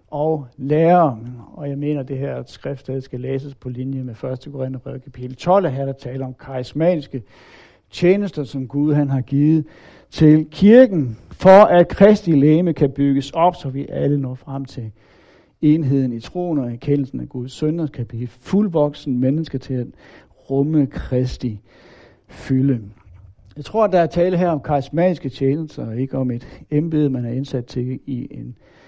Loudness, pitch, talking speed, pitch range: -18 LUFS, 140 Hz, 170 wpm, 130-155 Hz